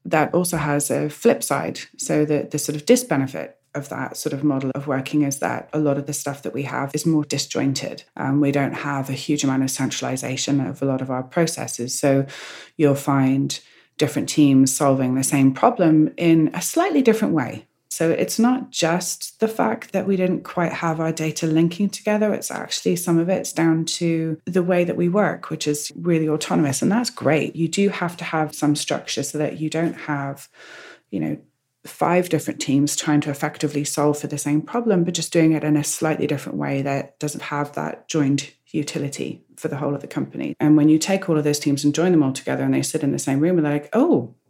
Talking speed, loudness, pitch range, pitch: 225 wpm, -21 LUFS, 140-165 Hz, 150 Hz